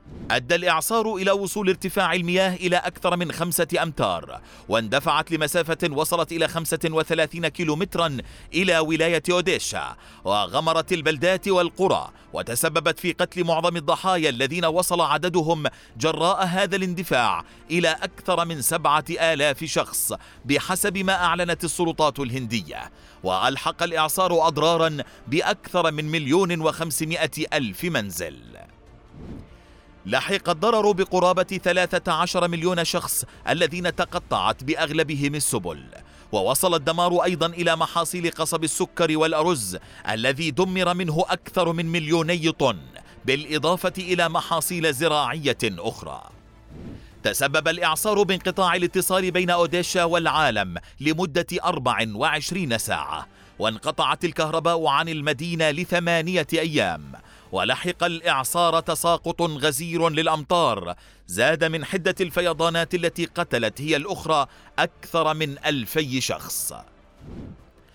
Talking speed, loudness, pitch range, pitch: 105 wpm, -23 LUFS, 155-180 Hz, 165 Hz